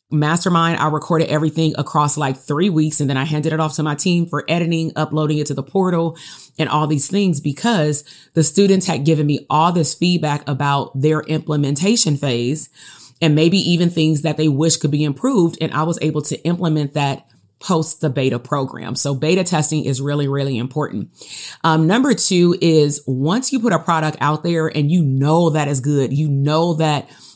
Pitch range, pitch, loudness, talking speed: 145-165 Hz, 155 Hz, -17 LUFS, 195 wpm